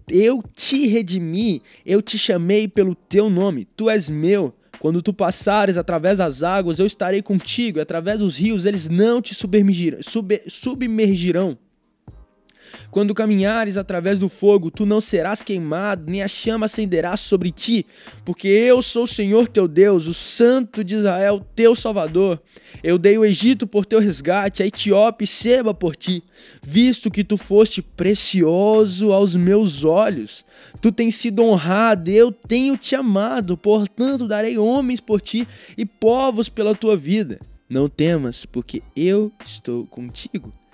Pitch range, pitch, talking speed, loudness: 185-220 Hz, 205 Hz, 150 wpm, -18 LUFS